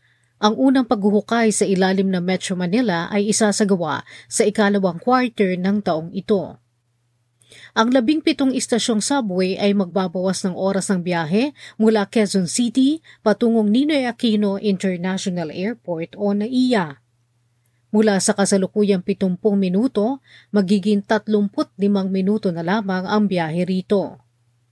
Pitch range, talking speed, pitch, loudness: 185-220 Hz, 125 wpm, 200 Hz, -19 LUFS